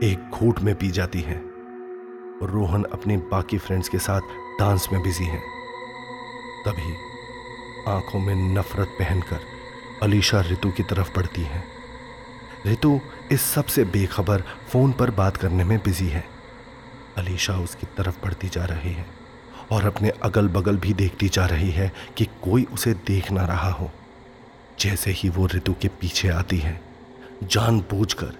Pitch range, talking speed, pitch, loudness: 95-120 Hz, 150 wpm, 100 Hz, -24 LUFS